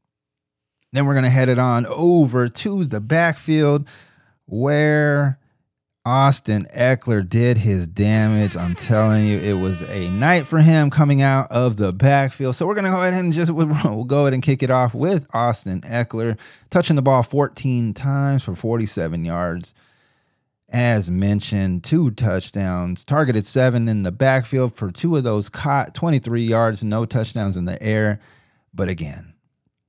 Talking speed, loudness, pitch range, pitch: 155 wpm, -19 LUFS, 105-140 Hz, 125 Hz